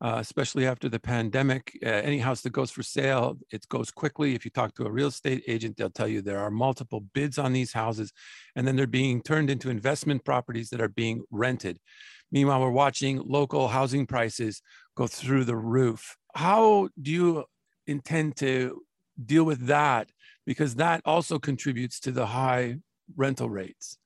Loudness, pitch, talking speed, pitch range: -27 LUFS, 130 Hz, 180 wpm, 120-145 Hz